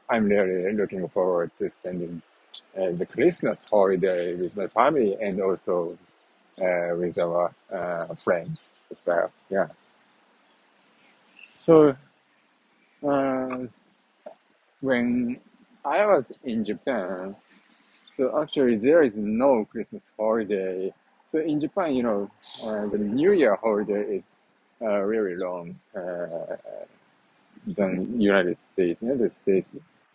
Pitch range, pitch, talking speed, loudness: 95-155 Hz, 115 Hz, 115 wpm, -25 LUFS